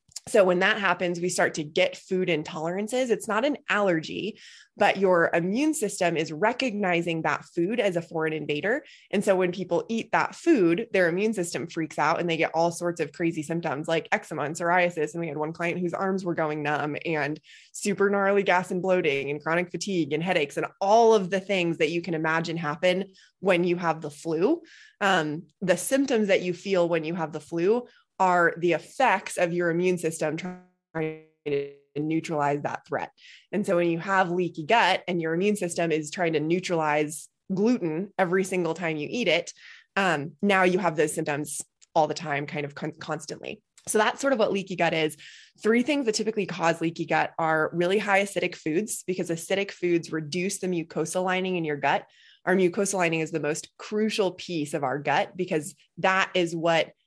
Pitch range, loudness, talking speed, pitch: 160-190 Hz, -26 LUFS, 200 wpm, 175 Hz